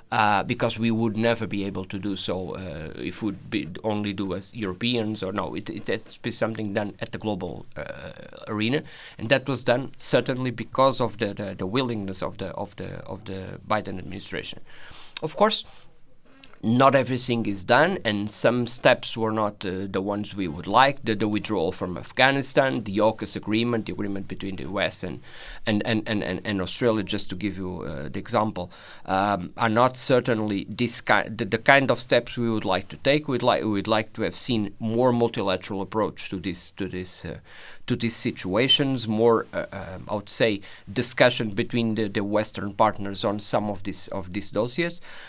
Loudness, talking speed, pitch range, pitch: -25 LUFS, 195 wpm, 100-120 Hz, 110 Hz